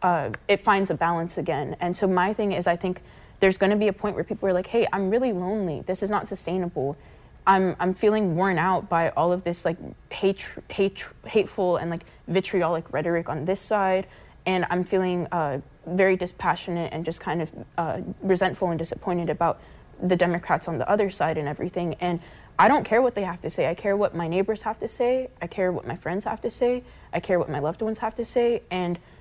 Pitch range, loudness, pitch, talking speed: 170-200 Hz, -25 LUFS, 180 Hz, 225 wpm